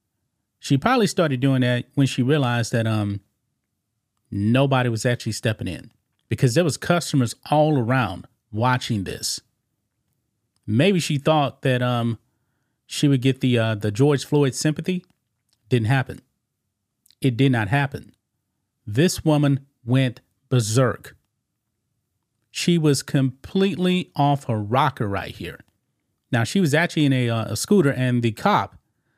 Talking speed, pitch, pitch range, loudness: 140 wpm, 125 Hz, 115-140 Hz, -21 LUFS